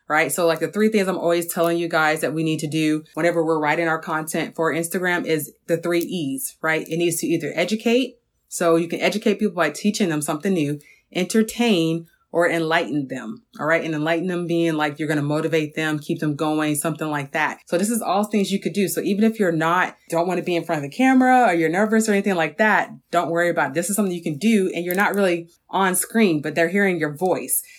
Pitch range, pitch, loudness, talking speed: 160-200 Hz, 170 Hz, -21 LUFS, 250 wpm